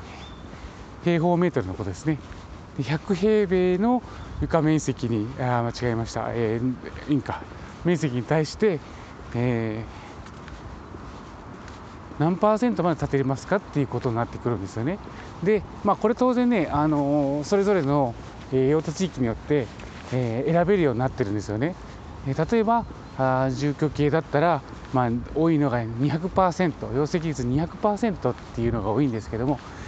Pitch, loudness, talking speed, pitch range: 140 Hz, -25 LUFS, 310 characters per minute, 115-165 Hz